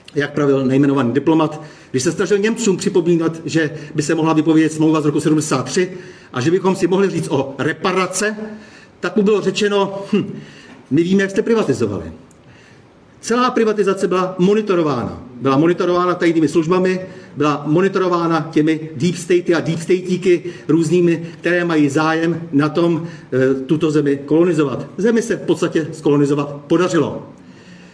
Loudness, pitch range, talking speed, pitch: -17 LUFS, 155-185 Hz, 145 wpm, 165 Hz